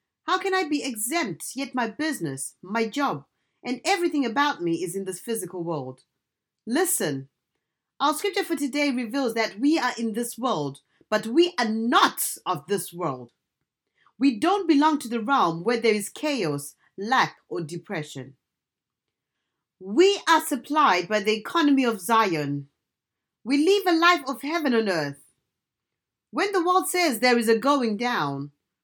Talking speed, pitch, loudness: 160 wpm, 235 Hz, -24 LUFS